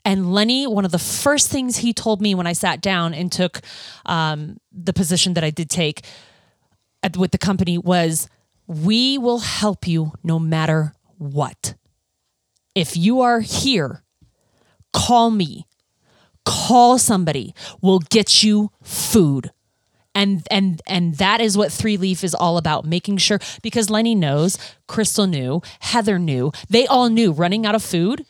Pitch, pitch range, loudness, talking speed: 185 Hz, 165-215 Hz, -18 LUFS, 155 wpm